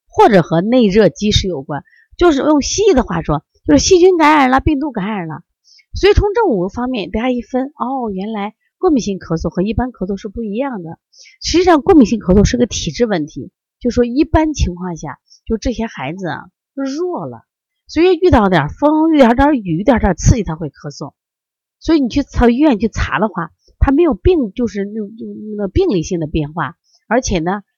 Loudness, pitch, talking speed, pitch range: -14 LUFS, 230 Hz, 300 characters per minute, 185-295 Hz